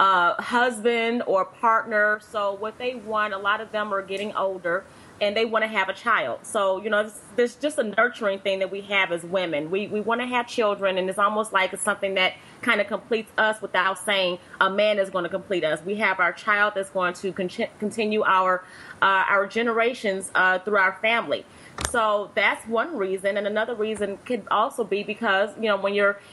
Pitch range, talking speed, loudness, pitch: 195-220 Hz, 210 wpm, -24 LUFS, 205 Hz